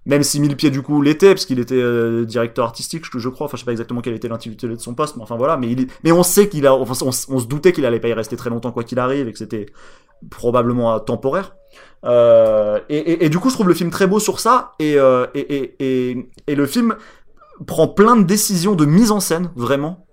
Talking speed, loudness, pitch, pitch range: 255 wpm, -17 LUFS, 135 Hz, 120-165 Hz